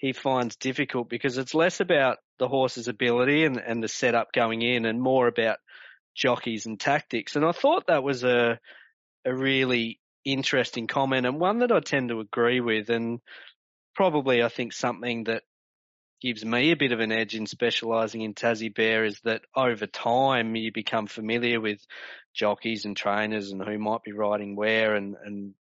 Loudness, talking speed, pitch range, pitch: -26 LUFS, 180 wpm, 110-125 Hz, 115 Hz